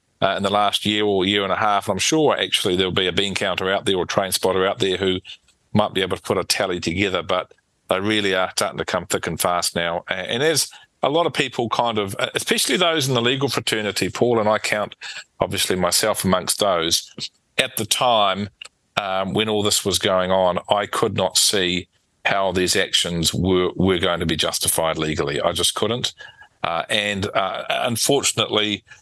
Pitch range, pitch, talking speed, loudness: 95-105 Hz, 100 Hz, 205 wpm, -20 LUFS